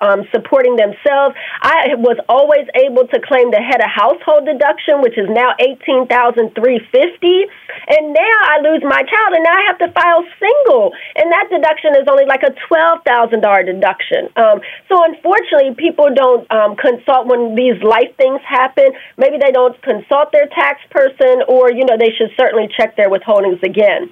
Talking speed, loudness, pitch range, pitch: 170 wpm, -12 LUFS, 240-330 Hz, 275 Hz